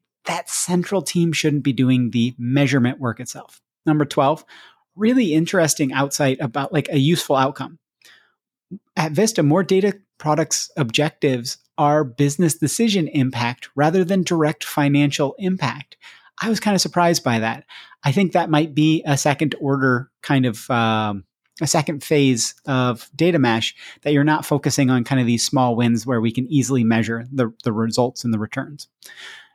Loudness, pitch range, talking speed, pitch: -19 LUFS, 125-160 Hz, 160 wpm, 145 Hz